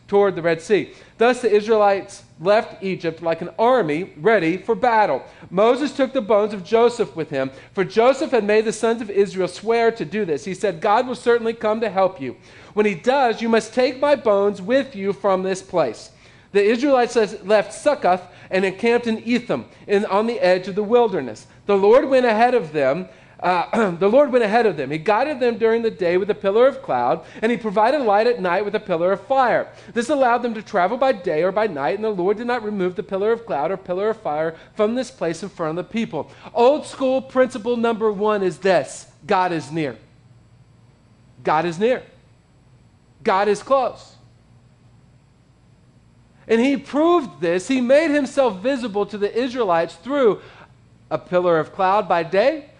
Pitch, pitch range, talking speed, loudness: 210 Hz, 180-240 Hz, 195 wpm, -20 LUFS